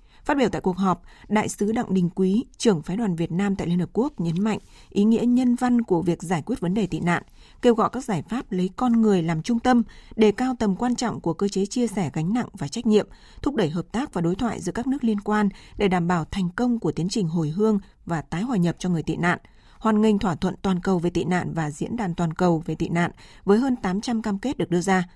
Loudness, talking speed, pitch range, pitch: -24 LUFS, 270 wpm, 175-225 Hz, 195 Hz